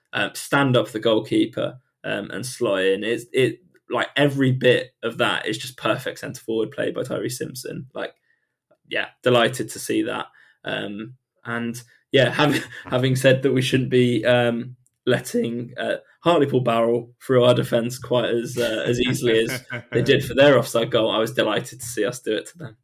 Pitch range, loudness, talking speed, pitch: 115-130 Hz, -22 LUFS, 185 wpm, 120 Hz